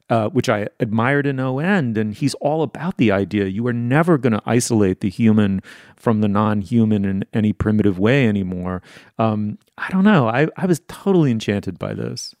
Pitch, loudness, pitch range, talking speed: 110 Hz, -19 LUFS, 105-140 Hz, 200 wpm